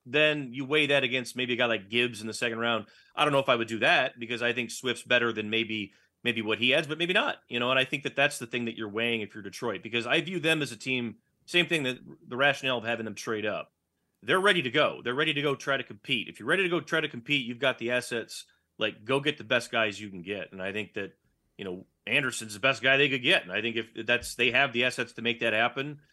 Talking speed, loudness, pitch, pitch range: 290 wpm, -27 LUFS, 120 Hz, 115-140 Hz